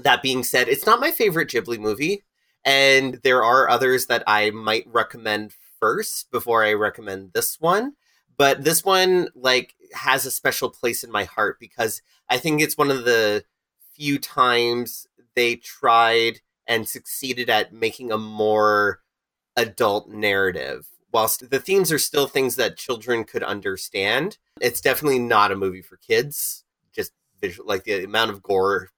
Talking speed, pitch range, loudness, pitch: 160 wpm, 110-155 Hz, -21 LUFS, 125 Hz